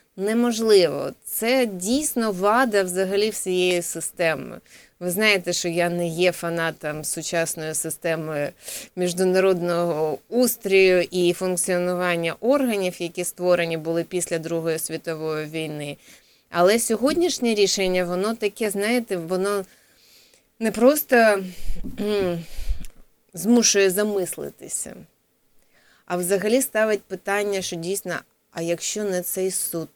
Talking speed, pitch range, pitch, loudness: 100 wpm, 170-210 Hz, 185 Hz, -22 LUFS